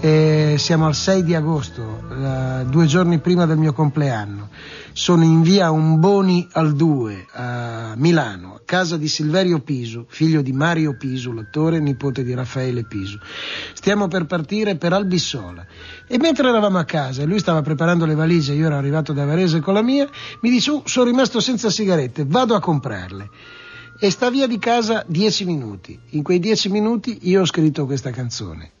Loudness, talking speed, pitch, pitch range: -18 LUFS, 180 wpm, 160 Hz, 130-185 Hz